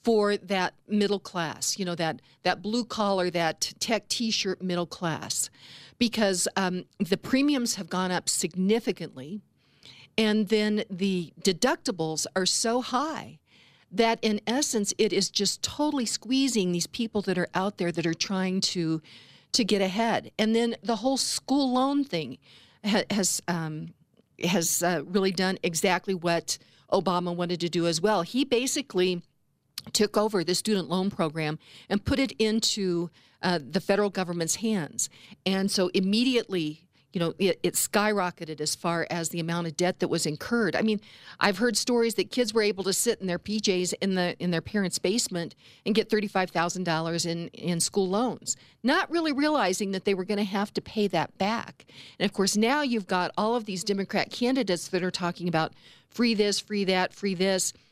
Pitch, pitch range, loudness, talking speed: 195 Hz, 175-220 Hz, -27 LUFS, 175 wpm